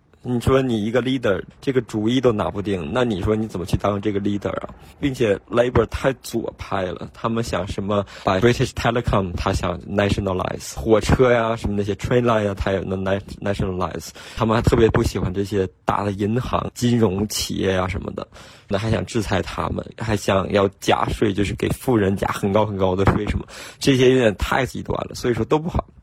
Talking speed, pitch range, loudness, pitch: 400 characters per minute, 95-120 Hz, -21 LUFS, 105 Hz